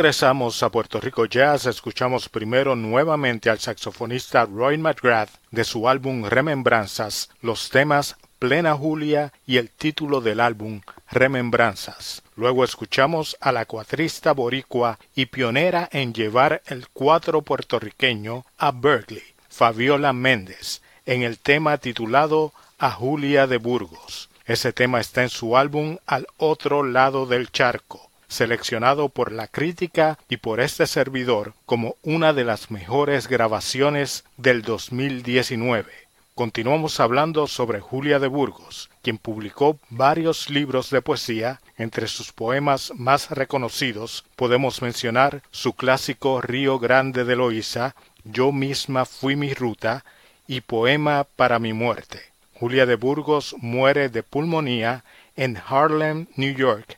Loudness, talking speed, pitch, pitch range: -21 LUFS, 130 wpm, 130 Hz, 120-140 Hz